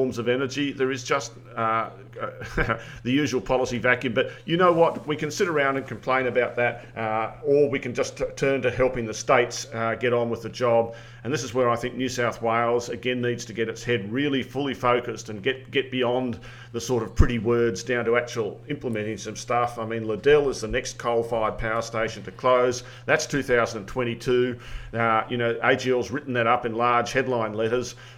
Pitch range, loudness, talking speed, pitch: 115-130 Hz, -25 LUFS, 205 wpm, 120 Hz